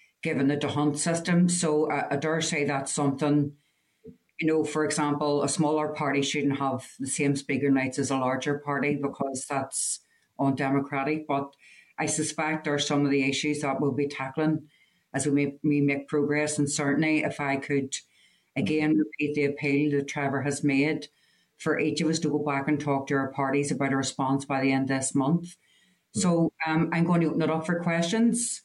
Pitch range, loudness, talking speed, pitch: 140-155 Hz, -27 LUFS, 195 wpm, 145 Hz